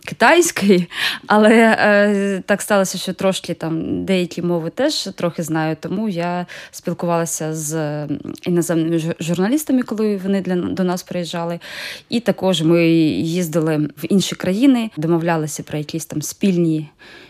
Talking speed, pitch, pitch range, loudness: 130 wpm, 175 Hz, 165-195 Hz, -18 LUFS